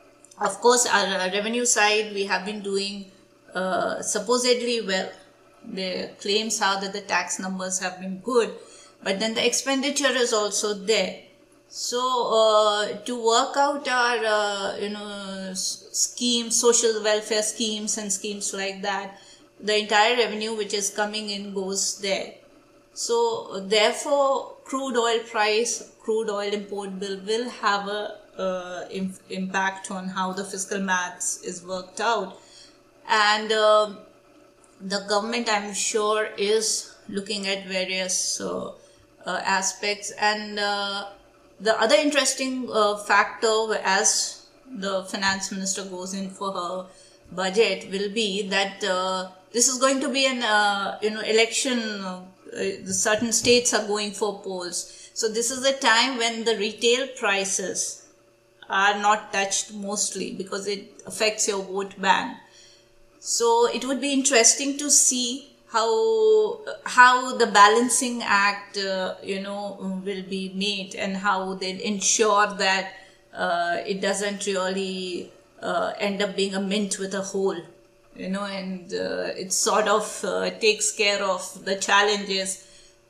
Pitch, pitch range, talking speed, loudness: 205 Hz, 195-225 Hz, 140 wpm, -23 LUFS